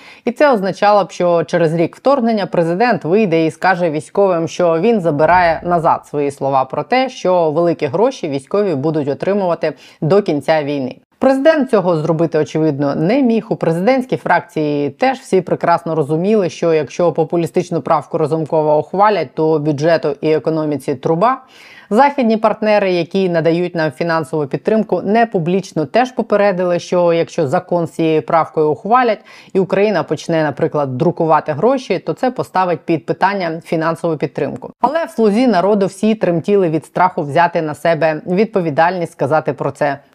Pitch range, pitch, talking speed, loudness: 160-205 Hz, 170 Hz, 150 wpm, -15 LUFS